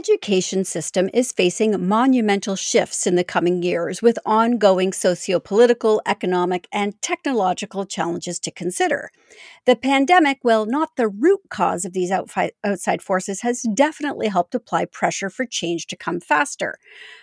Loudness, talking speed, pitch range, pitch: -20 LUFS, 150 wpm, 185-240 Hz, 200 Hz